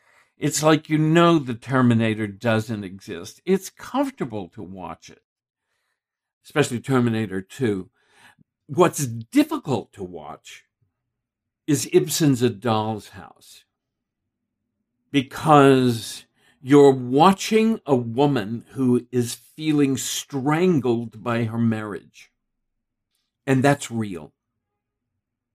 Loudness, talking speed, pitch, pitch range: -21 LUFS, 95 wpm, 125 Hz, 115-145 Hz